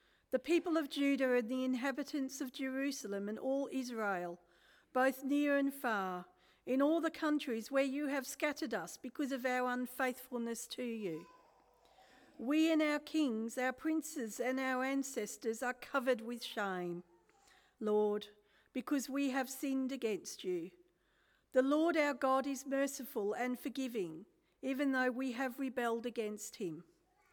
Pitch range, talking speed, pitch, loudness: 230-280 Hz, 145 wpm, 260 Hz, -37 LUFS